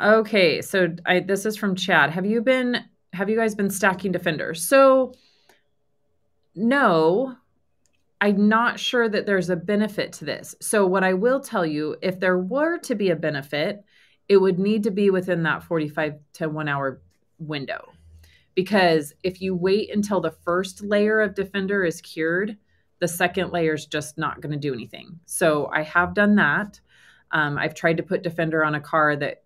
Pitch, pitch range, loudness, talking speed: 185 Hz, 155-205 Hz, -22 LUFS, 180 wpm